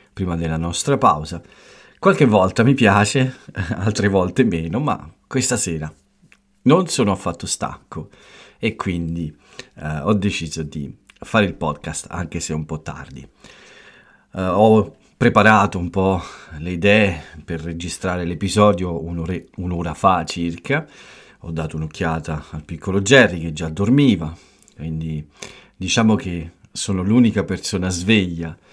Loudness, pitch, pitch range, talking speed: -19 LUFS, 90 Hz, 80-100 Hz, 130 wpm